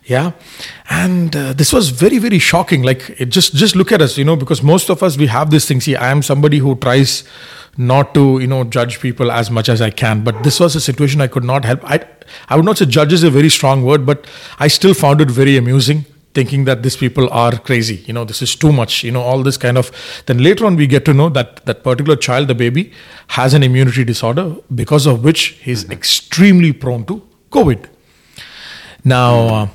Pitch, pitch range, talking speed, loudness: 140 Hz, 125-155 Hz, 230 wpm, -12 LUFS